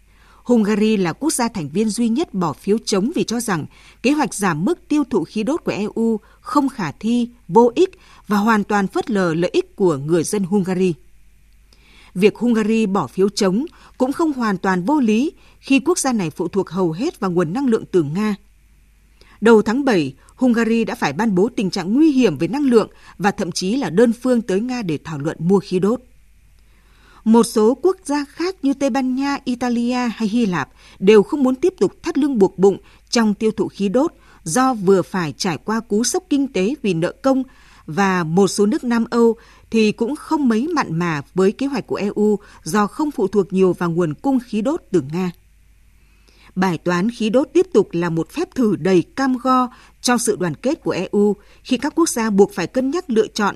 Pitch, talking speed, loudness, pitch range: 220 Hz, 215 wpm, -19 LUFS, 190-255 Hz